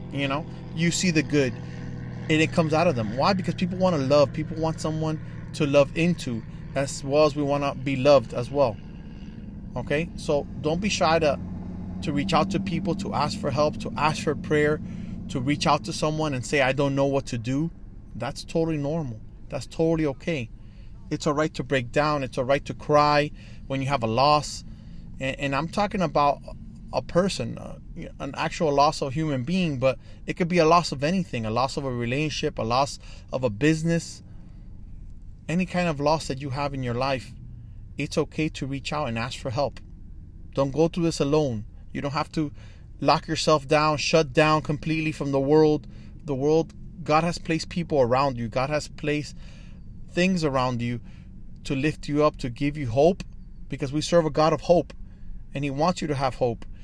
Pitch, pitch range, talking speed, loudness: 145 Hz, 125-155 Hz, 205 wpm, -25 LUFS